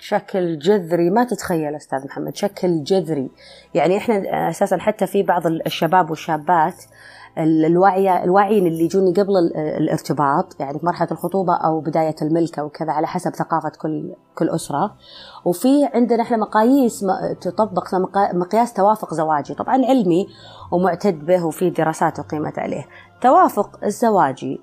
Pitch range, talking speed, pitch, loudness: 160-200 Hz, 125 wpm, 180 Hz, -19 LUFS